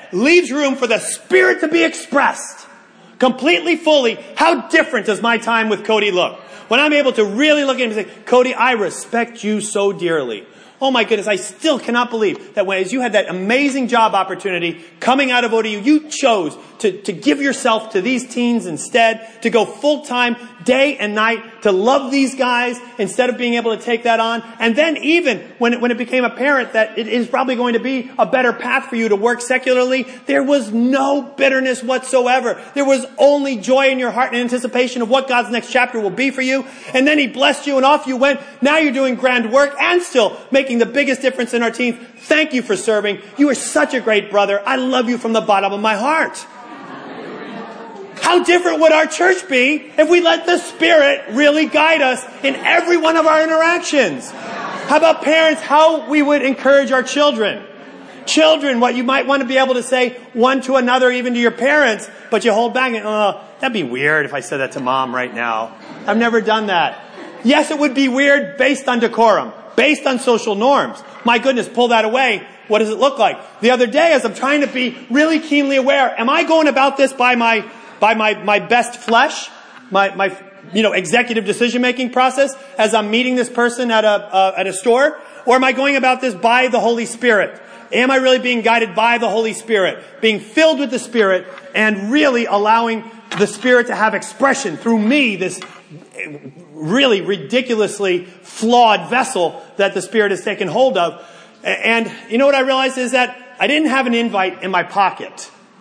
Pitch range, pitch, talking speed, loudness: 225-275 Hz, 250 Hz, 205 wpm, -15 LUFS